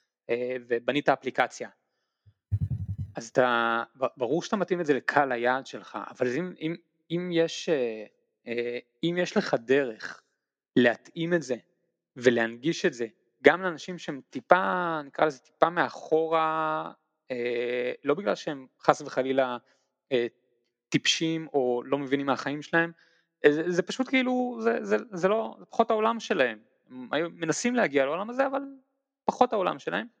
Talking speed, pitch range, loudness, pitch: 130 wpm, 125-175 Hz, -28 LUFS, 150 Hz